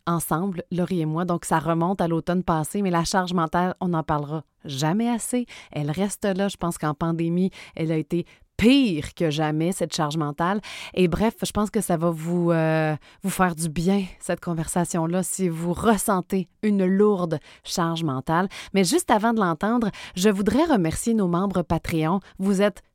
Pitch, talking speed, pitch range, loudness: 175 Hz, 185 wpm, 165-200 Hz, -24 LUFS